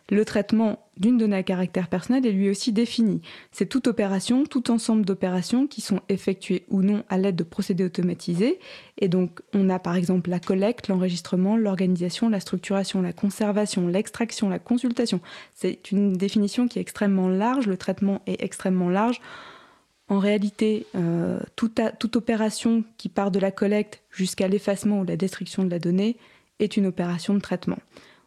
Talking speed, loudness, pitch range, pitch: 170 wpm, -24 LUFS, 185-225 Hz, 200 Hz